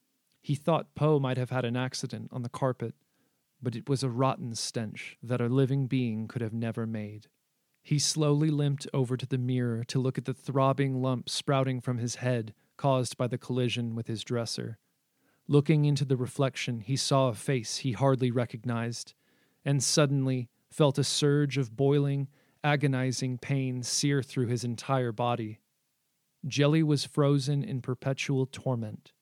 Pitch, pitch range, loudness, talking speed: 130 Hz, 120-140 Hz, -29 LUFS, 165 wpm